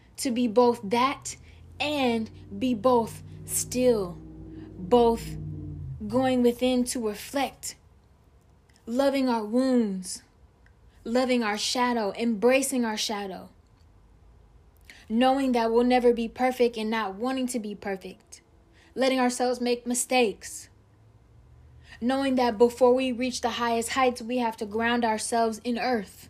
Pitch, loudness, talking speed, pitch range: 235 Hz, -26 LUFS, 120 wpm, 190-250 Hz